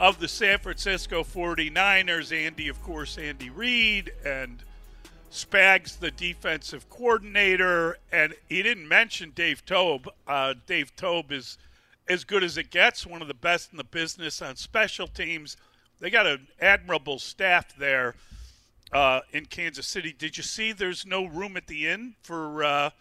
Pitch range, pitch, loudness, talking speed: 145-185 Hz, 165 Hz, -25 LUFS, 160 wpm